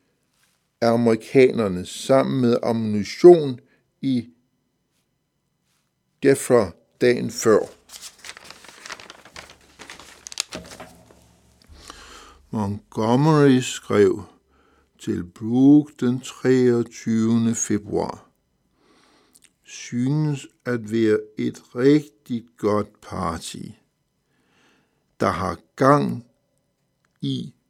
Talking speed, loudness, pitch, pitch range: 60 wpm, -21 LUFS, 120 Hz, 105-130 Hz